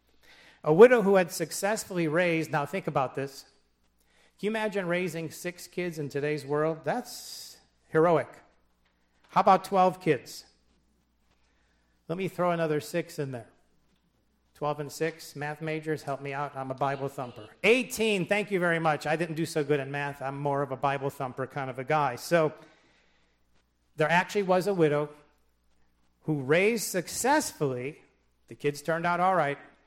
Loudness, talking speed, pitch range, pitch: -28 LUFS, 165 wpm, 130-175 Hz, 150 Hz